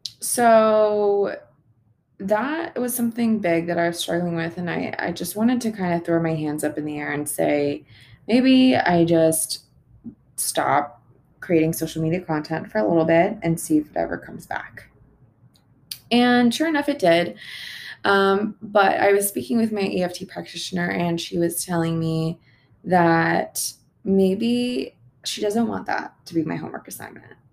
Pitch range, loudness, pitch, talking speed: 150-210 Hz, -21 LUFS, 170 Hz, 165 wpm